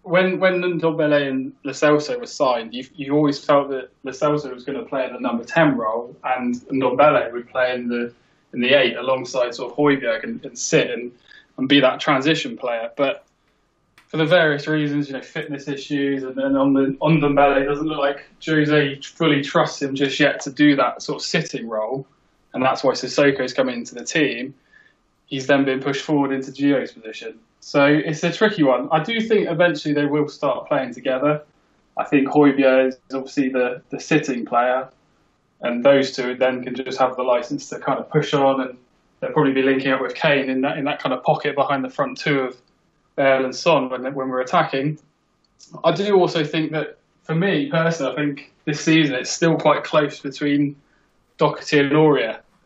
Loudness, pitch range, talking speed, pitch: -20 LUFS, 130-155 Hz, 200 wpm, 140 Hz